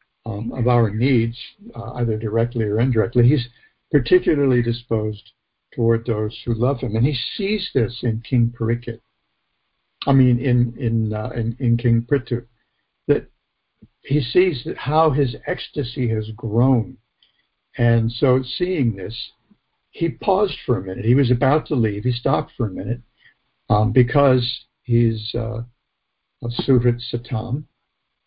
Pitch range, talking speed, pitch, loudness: 115-130 Hz, 140 wpm, 120 Hz, -20 LUFS